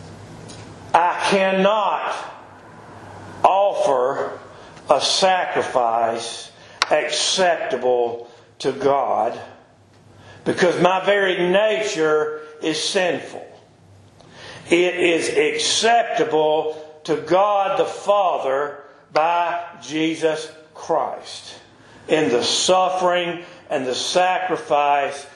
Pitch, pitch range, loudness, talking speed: 160 Hz, 145-190 Hz, -19 LUFS, 70 wpm